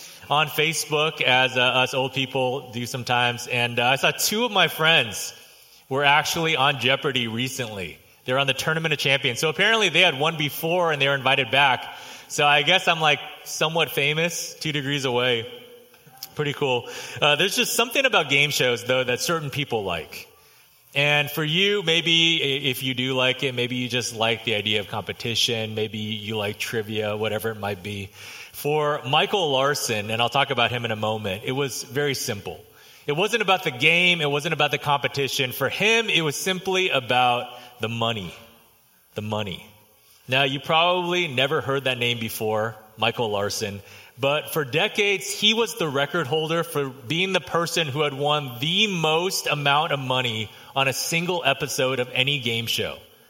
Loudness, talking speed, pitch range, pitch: -22 LUFS, 180 wpm, 120-160 Hz, 140 Hz